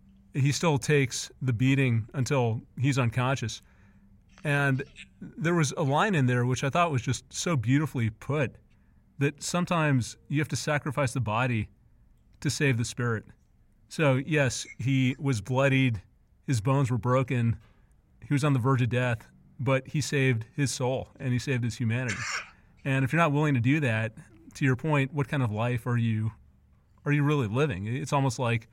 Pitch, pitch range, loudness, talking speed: 130 Hz, 115-145 Hz, -28 LUFS, 180 wpm